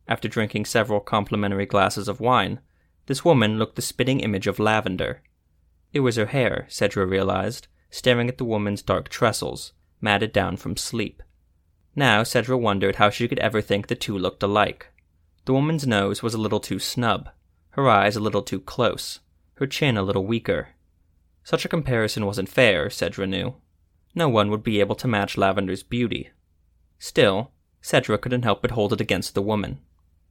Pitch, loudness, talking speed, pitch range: 100 Hz, -23 LUFS, 175 wpm, 85-120 Hz